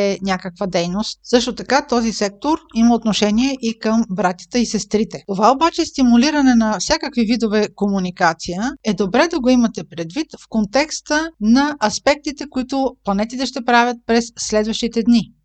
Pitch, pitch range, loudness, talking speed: 230 Hz, 210-265 Hz, -18 LUFS, 150 wpm